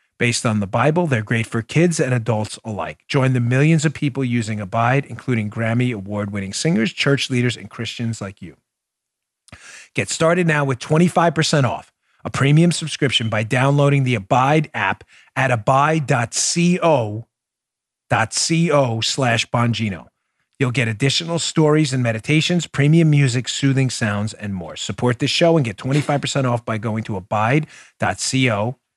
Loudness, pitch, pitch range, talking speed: -19 LUFS, 130 Hz, 115-150 Hz, 145 wpm